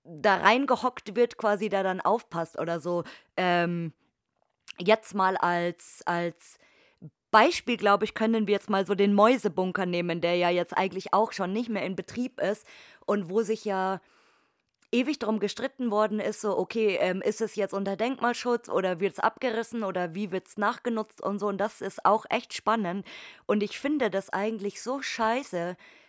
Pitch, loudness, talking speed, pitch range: 205 Hz, -28 LUFS, 175 wpm, 185-225 Hz